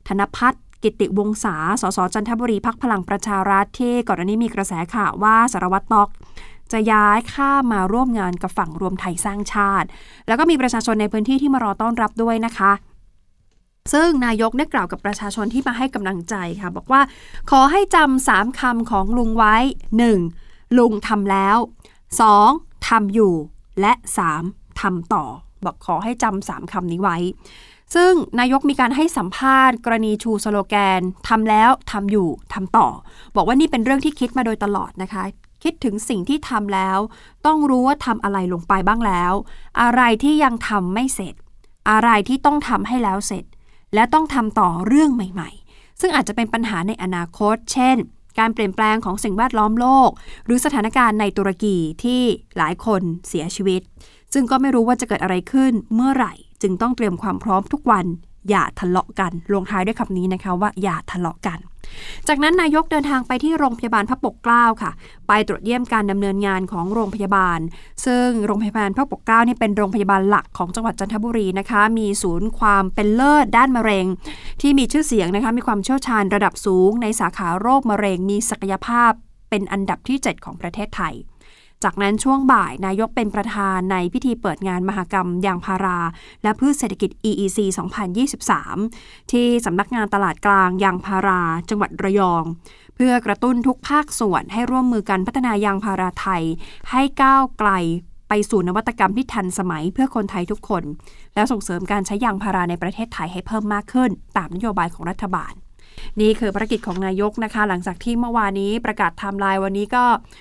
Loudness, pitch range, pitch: -19 LUFS, 195-240 Hz, 210 Hz